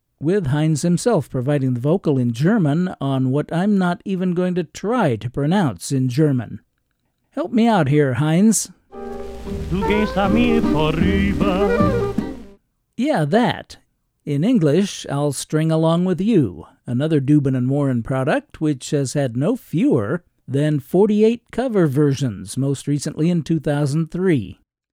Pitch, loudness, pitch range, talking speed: 150 Hz, -19 LUFS, 135-180 Hz, 125 wpm